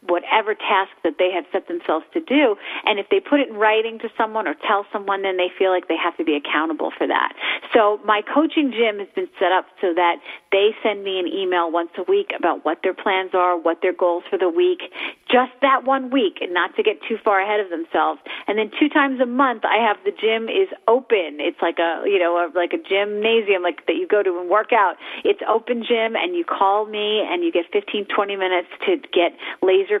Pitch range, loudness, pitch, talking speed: 185-270 Hz, -20 LUFS, 210 Hz, 240 wpm